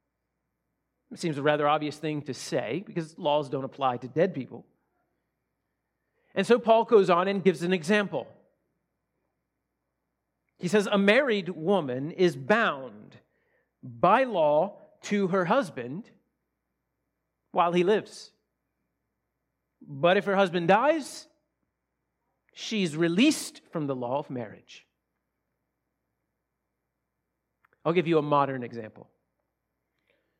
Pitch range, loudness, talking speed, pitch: 145-215 Hz, -26 LUFS, 115 wpm, 180 Hz